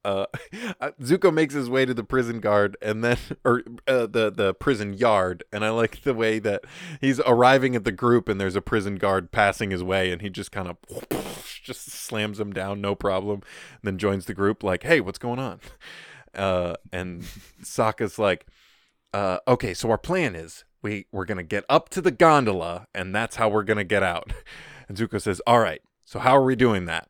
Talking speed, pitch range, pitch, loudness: 205 wpm, 100-125 Hz, 105 Hz, -24 LUFS